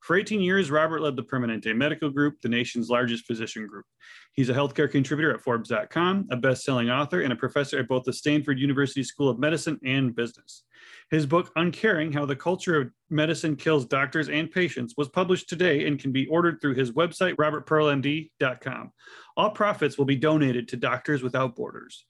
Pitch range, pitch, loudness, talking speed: 130-160 Hz, 145 Hz, -25 LUFS, 185 wpm